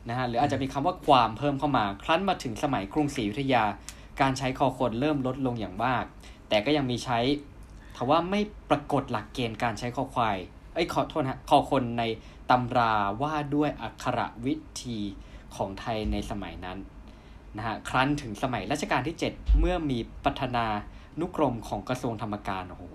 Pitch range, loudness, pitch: 105-140 Hz, -28 LUFS, 125 Hz